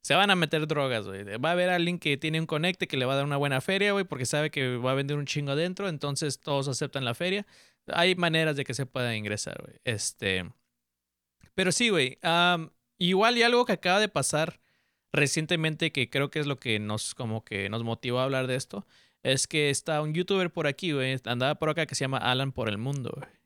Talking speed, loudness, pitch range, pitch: 230 wpm, -27 LUFS, 130-165 Hz, 145 Hz